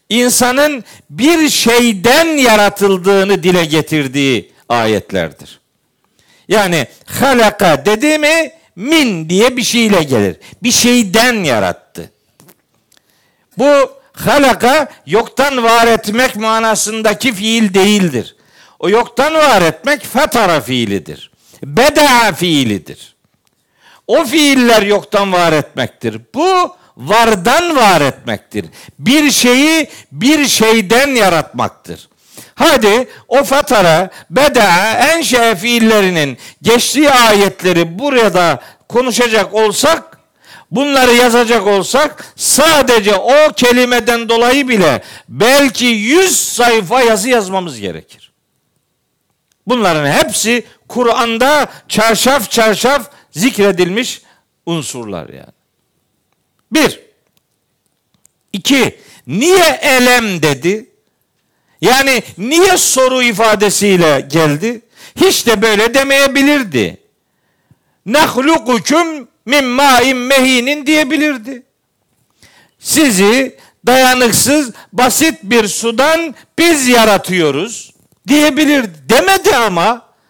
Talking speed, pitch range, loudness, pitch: 80 wpm, 200-275 Hz, -10 LUFS, 235 Hz